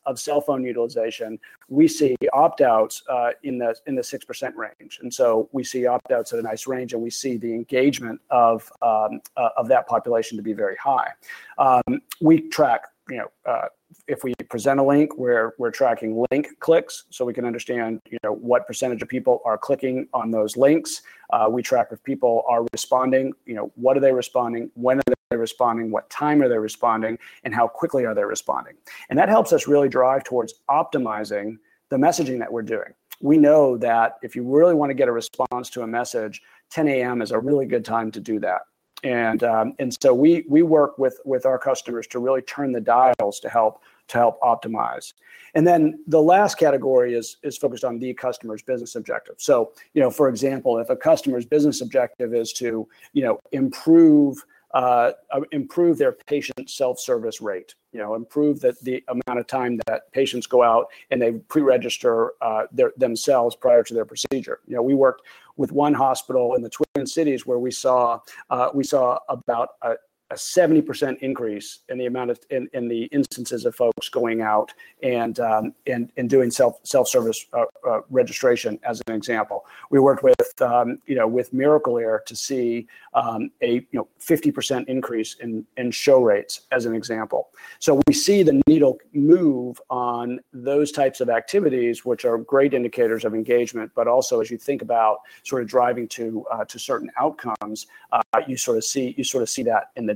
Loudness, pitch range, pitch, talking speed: -21 LUFS, 115-150 Hz, 130 Hz, 195 wpm